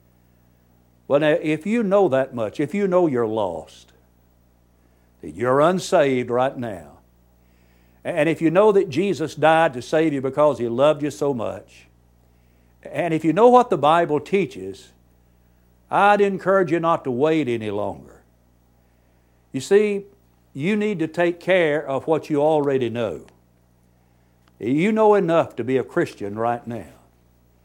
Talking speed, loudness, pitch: 150 wpm, -20 LUFS, 120 Hz